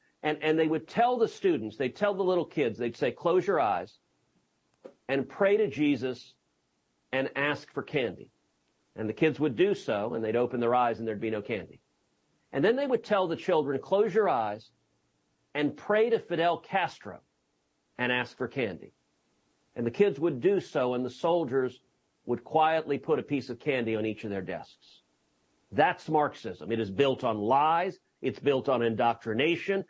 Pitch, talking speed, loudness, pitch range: 130 Hz, 185 wpm, -29 LUFS, 110-165 Hz